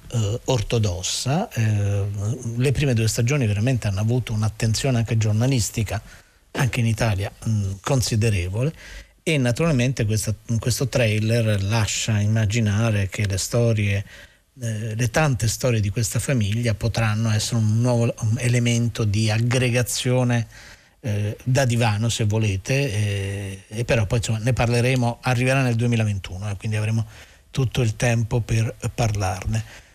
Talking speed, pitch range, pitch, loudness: 115 wpm, 105-125 Hz, 115 Hz, -22 LUFS